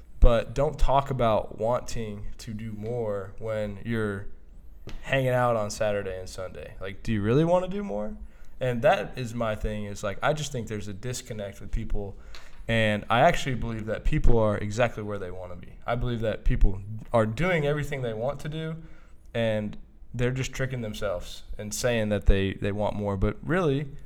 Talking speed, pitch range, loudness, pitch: 190 wpm, 100-125 Hz, -28 LUFS, 110 Hz